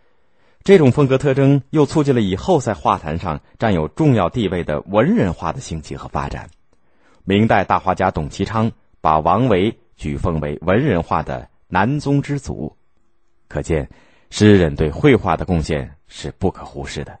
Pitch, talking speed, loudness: 95 Hz, 245 characters per minute, -18 LUFS